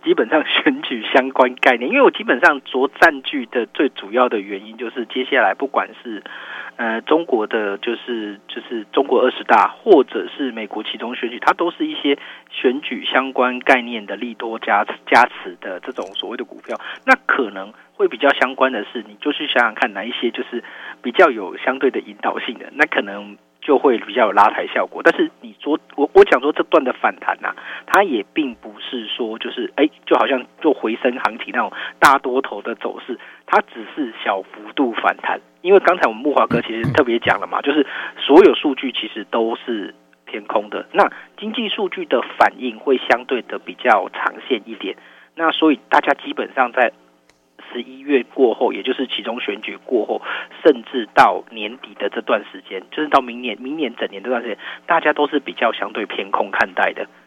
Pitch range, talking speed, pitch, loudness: 115-160 Hz, 290 characters per minute, 130 Hz, -18 LUFS